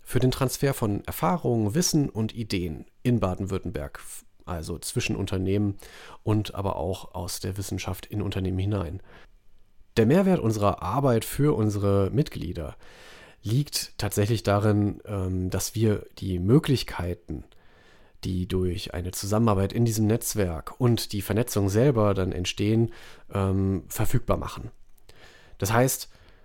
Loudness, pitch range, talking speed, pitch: -26 LUFS, 95-115 Hz, 120 wpm, 100 Hz